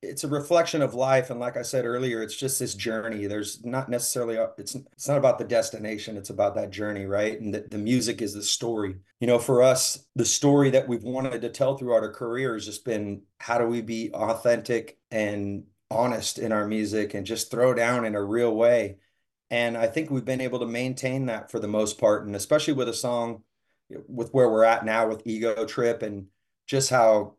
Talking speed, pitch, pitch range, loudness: 220 wpm, 115 Hz, 110-125 Hz, -25 LUFS